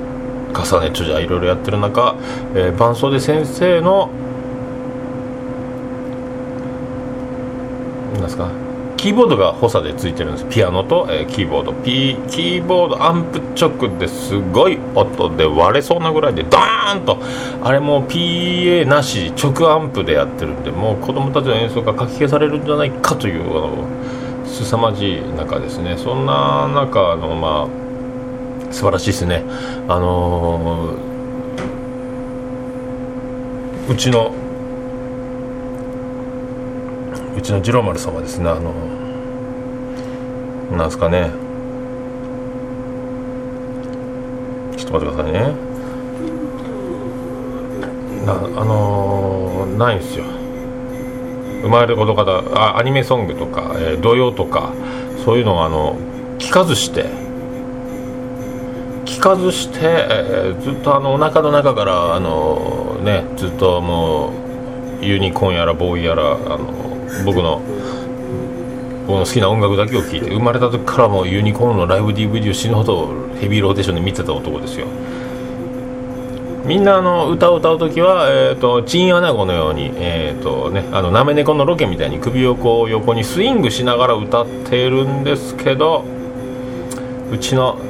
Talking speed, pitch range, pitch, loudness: 265 characters per minute, 115-125 Hz, 125 Hz, -17 LUFS